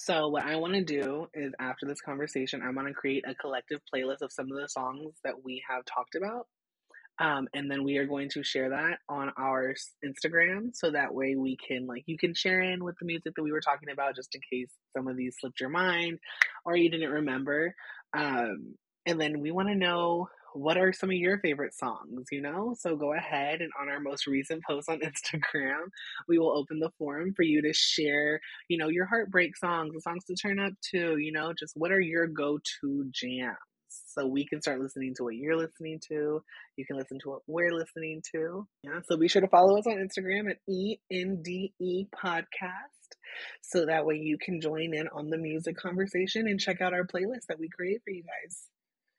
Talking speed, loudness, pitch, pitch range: 220 wpm, -31 LUFS, 160 Hz, 140-180 Hz